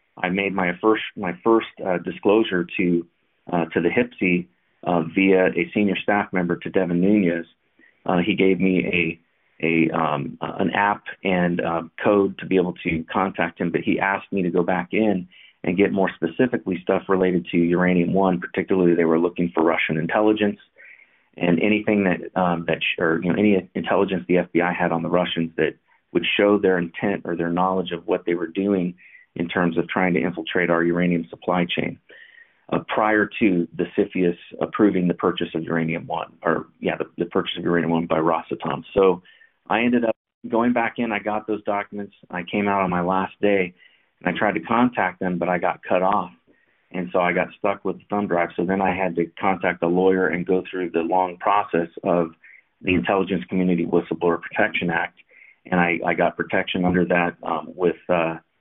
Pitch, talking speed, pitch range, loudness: 90 Hz, 200 wpm, 85-100 Hz, -22 LUFS